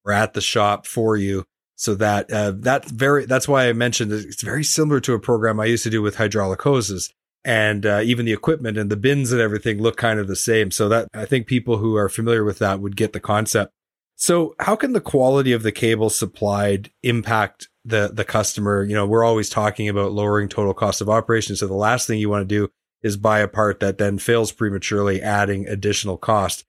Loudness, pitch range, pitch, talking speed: -20 LUFS, 105-115 Hz, 110 Hz, 225 wpm